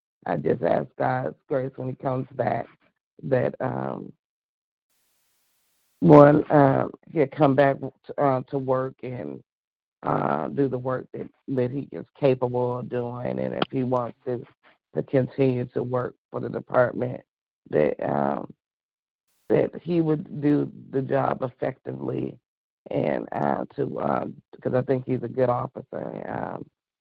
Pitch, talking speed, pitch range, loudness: 130 Hz, 145 wpm, 125-135 Hz, -25 LUFS